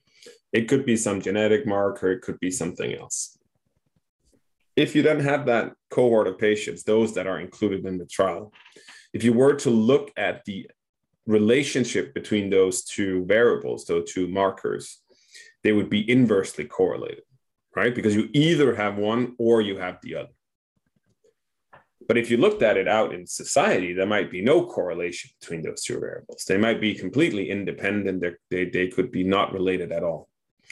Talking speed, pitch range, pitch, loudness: 170 wpm, 95-155 Hz, 110 Hz, -23 LUFS